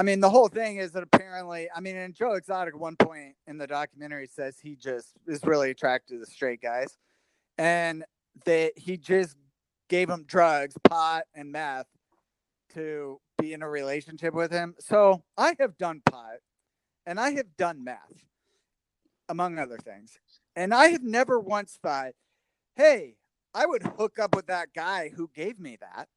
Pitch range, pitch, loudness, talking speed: 150-190 Hz, 170 Hz, -26 LUFS, 175 wpm